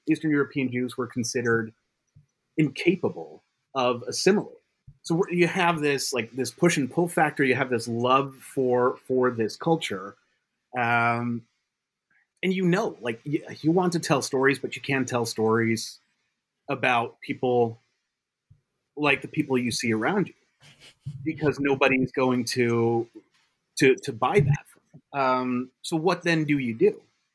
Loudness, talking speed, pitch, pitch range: -25 LUFS, 145 wpm, 135 Hz, 125-160 Hz